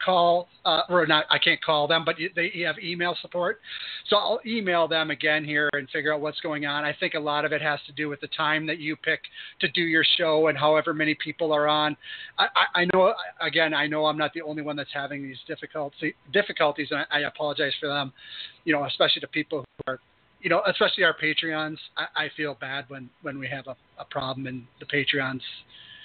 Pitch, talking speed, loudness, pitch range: 150 Hz, 230 wpm, -25 LUFS, 145-165 Hz